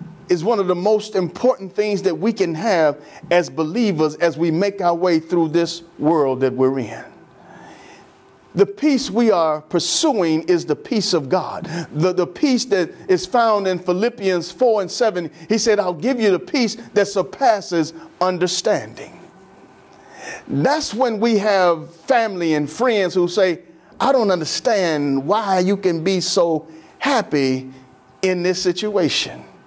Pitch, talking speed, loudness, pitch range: 180 Hz, 155 wpm, -19 LUFS, 165-210 Hz